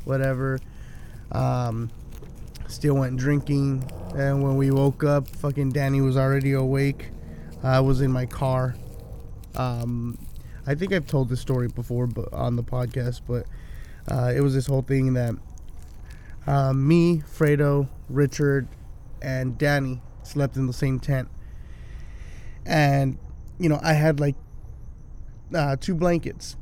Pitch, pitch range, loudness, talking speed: 130 Hz, 120-140 Hz, -24 LUFS, 140 wpm